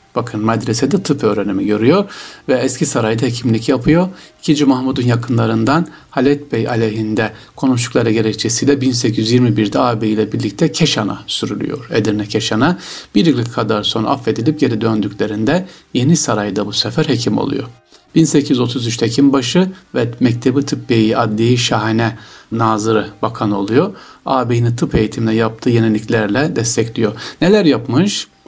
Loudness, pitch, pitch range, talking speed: -15 LUFS, 120 Hz, 110-135 Hz, 120 wpm